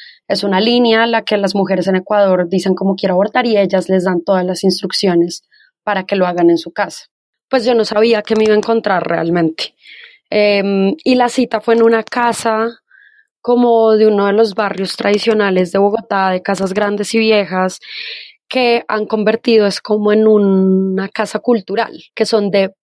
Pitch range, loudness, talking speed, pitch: 190-225 Hz, -14 LUFS, 190 wpm, 210 Hz